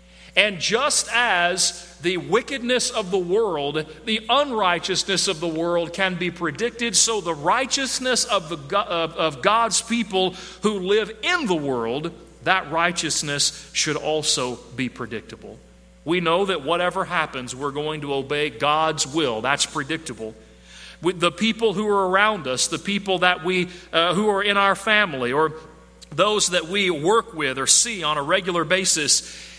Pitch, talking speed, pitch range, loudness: 175 Hz, 160 wpm, 155-200 Hz, -21 LUFS